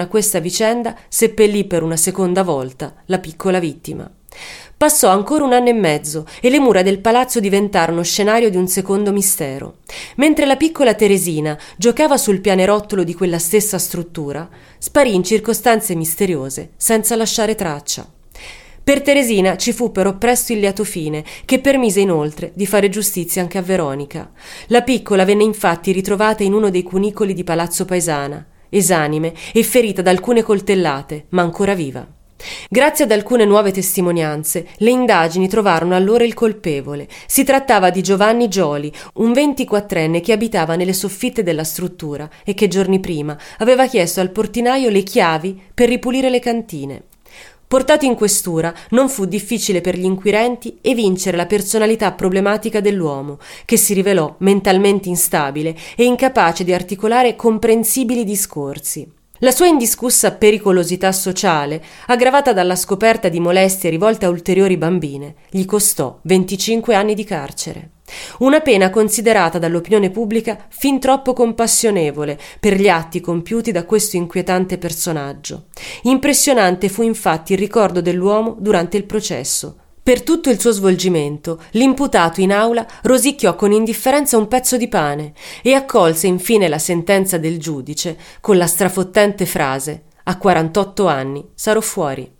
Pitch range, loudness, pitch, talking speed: 175-225 Hz, -15 LUFS, 195 Hz, 145 wpm